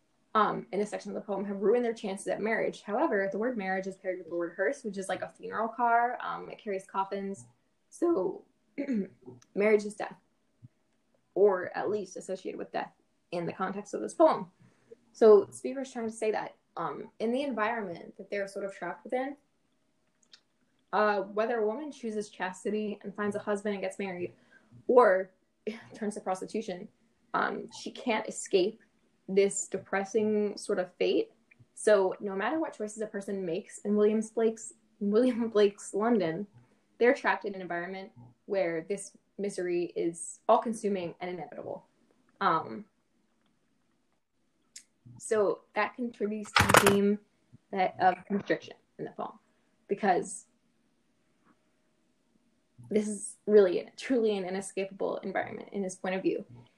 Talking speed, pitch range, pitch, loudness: 150 wpm, 190-220 Hz, 205 Hz, -30 LUFS